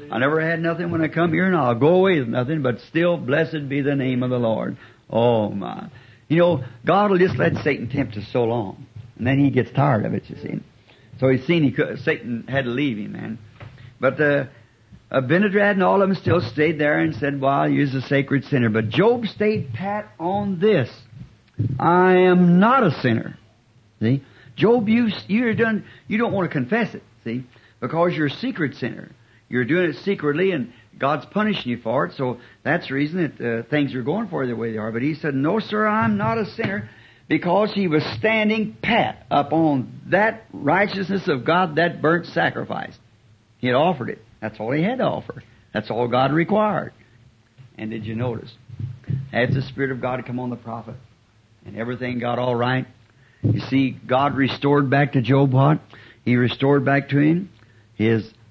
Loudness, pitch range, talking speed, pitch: -21 LUFS, 120-170 Hz, 200 wpm, 135 Hz